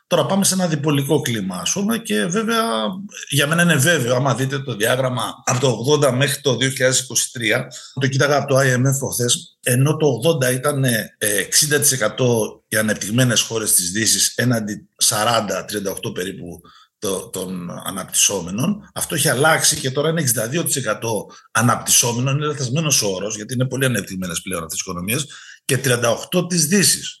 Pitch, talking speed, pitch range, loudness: 135 Hz, 150 wpm, 120-155 Hz, -18 LUFS